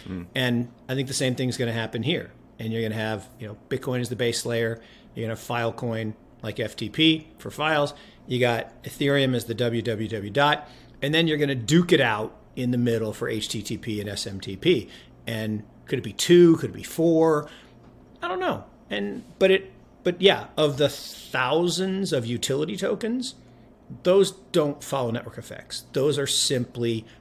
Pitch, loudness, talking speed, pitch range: 125 Hz, -25 LUFS, 180 wpm, 115-145 Hz